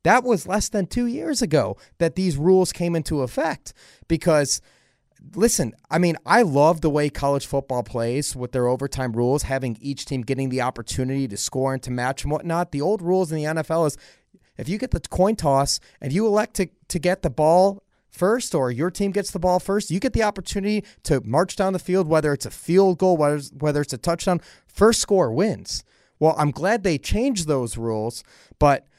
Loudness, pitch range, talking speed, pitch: -22 LUFS, 135-185 Hz, 210 wpm, 160 Hz